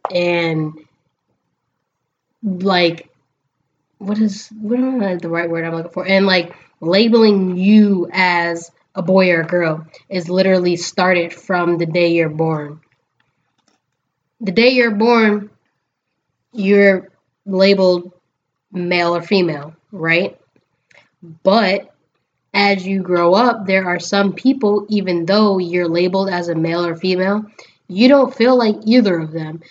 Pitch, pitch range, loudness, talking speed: 180 Hz, 170-200 Hz, -15 LUFS, 130 wpm